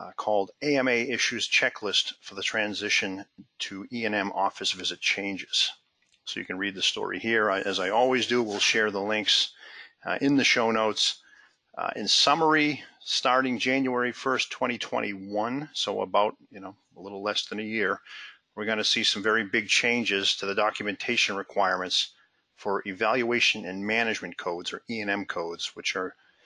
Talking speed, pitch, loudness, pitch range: 165 wpm, 105 Hz, -26 LUFS, 100-120 Hz